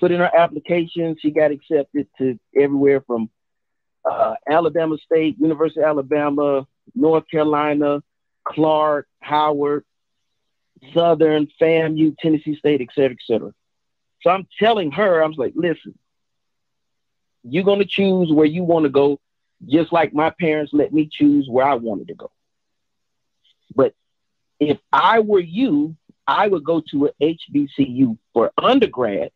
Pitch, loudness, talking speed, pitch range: 155 Hz, -18 LUFS, 140 wpm, 145-170 Hz